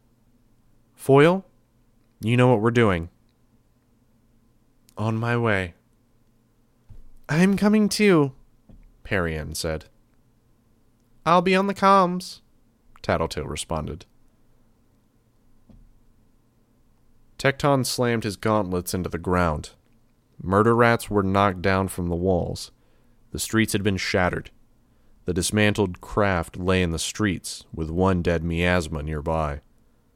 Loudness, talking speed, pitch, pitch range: -23 LUFS, 105 wpm, 115 Hz, 95-120 Hz